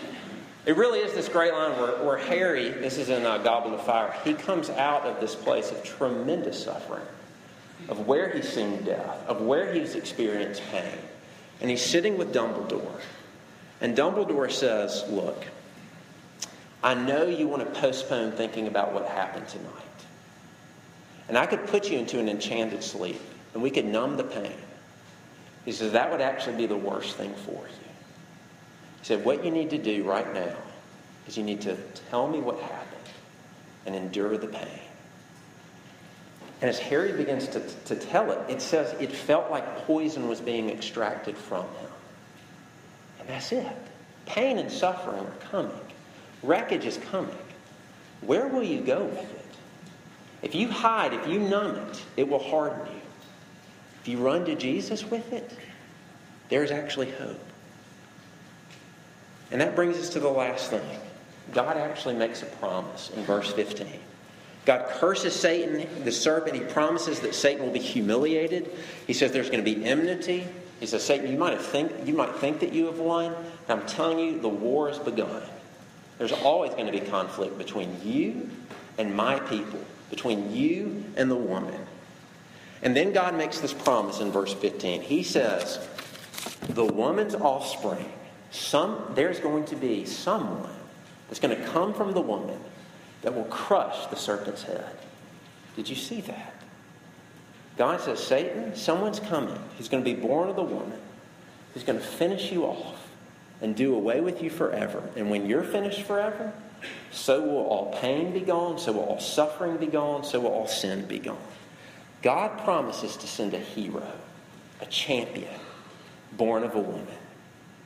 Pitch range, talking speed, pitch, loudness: 110-170 Hz, 165 wpm, 145 Hz, -28 LUFS